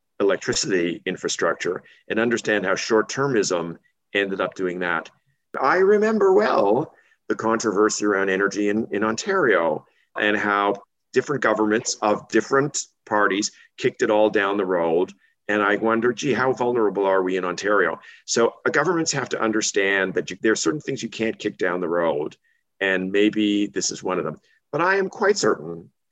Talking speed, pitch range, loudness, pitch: 170 wpm, 100-120 Hz, -22 LUFS, 105 Hz